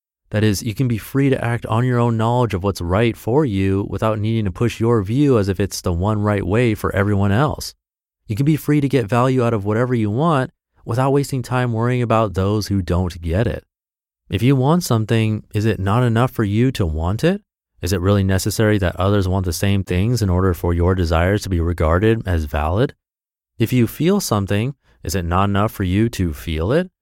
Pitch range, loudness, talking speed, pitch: 95-120 Hz, -19 LUFS, 225 wpm, 105 Hz